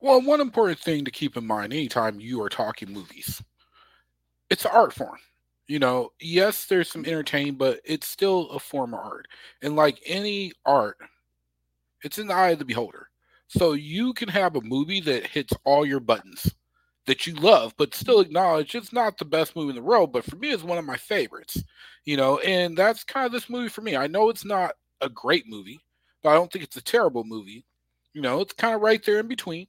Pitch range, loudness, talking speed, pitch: 130-205 Hz, -24 LUFS, 220 wpm, 160 Hz